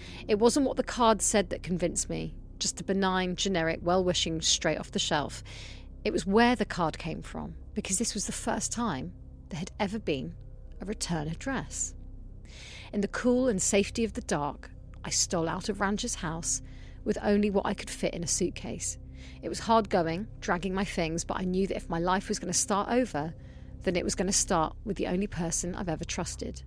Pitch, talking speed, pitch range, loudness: 185 Hz, 210 wpm, 155-210 Hz, -29 LUFS